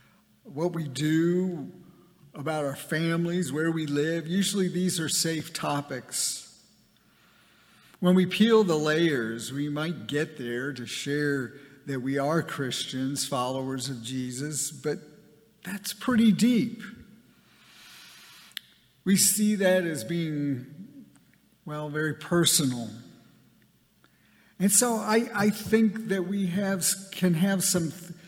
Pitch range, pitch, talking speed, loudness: 145-195 Hz, 165 Hz, 115 wpm, -27 LUFS